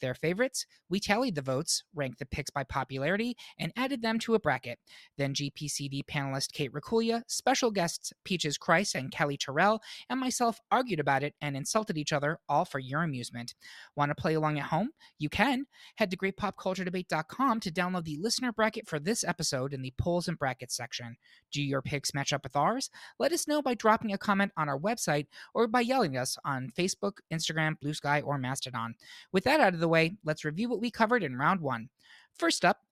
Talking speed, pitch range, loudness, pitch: 200 wpm, 145-220 Hz, -31 LUFS, 165 Hz